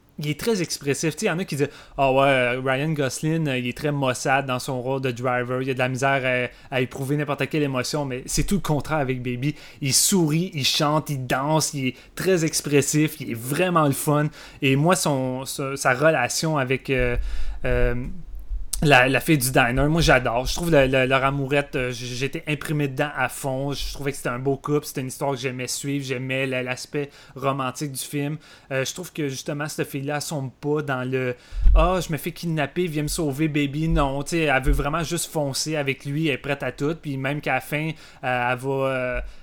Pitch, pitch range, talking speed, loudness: 140 Hz, 130-150 Hz, 230 wpm, -23 LUFS